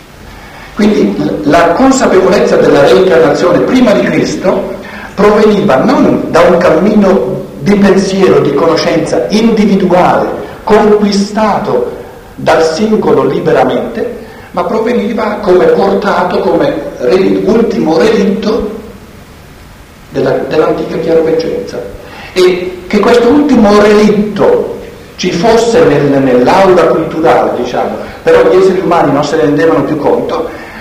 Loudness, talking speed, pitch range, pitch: -8 LUFS, 105 wpm, 160-215 Hz, 195 Hz